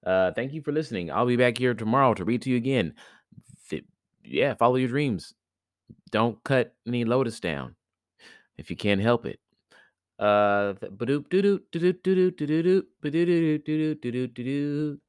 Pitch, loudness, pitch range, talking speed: 130 Hz, -25 LUFS, 120-155 Hz, 160 wpm